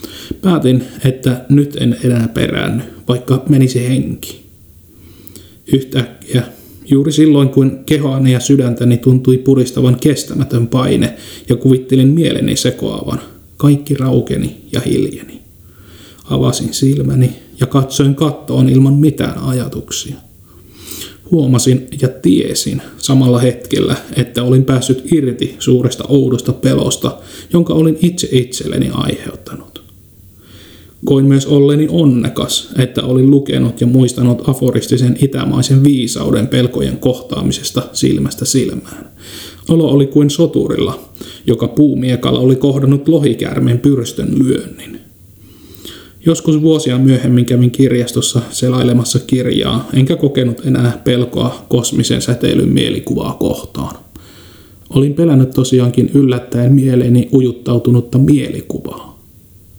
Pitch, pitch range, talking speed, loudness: 130 Hz, 125-140 Hz, 100 wpm, -13 LUFS